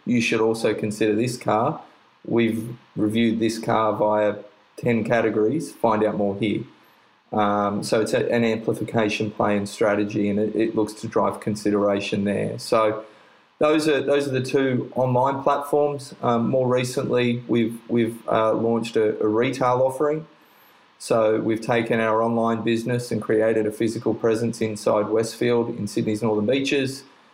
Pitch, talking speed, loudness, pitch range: 115 Hz, 155 wpm, -22 LUFS, 110-120 Hz